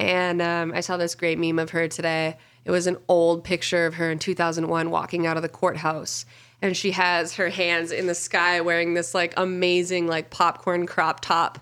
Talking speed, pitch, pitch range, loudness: 205 wpm, 170 Hz, 165-180 Hz, -23 LUFS